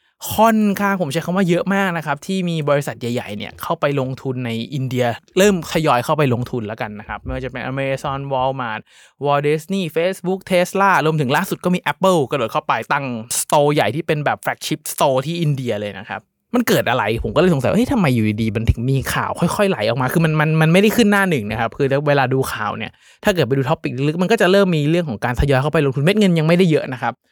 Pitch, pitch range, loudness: 150 Hz, 130-180 Hz, -18 LUFS